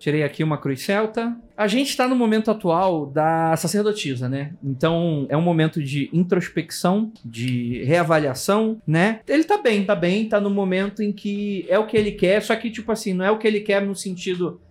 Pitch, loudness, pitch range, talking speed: 190 Hz, -21 LUFS, 160-210 Hz, 205 wpm